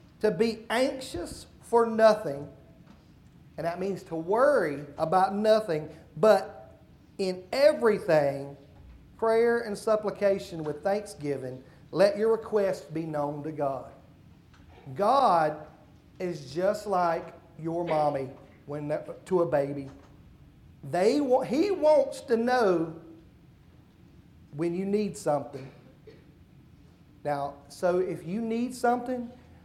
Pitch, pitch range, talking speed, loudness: 180 Hz, 150-220 Hz, 105 wpm, -27 LUFS